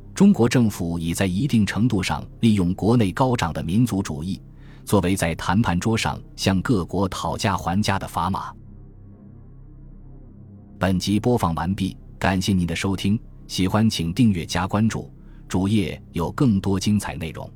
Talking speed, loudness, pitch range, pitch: 230 characters per minute, -22 LUFS, 90-115 Hz, 100 Hz